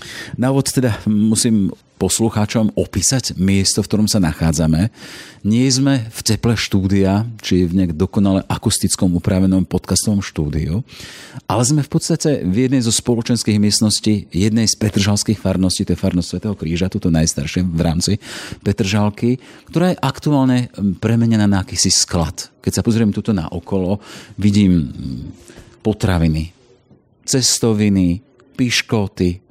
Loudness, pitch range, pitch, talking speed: -17 LUFS, 95-115 Hz, 105 Hz, 130 wpm